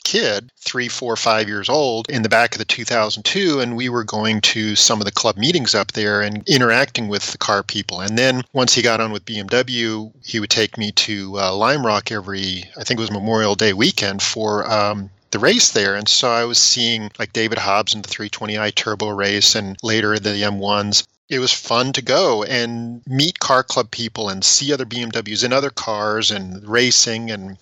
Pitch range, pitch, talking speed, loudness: 105-120 Hz, 110 Hz, 210 wpm, -17 LUFS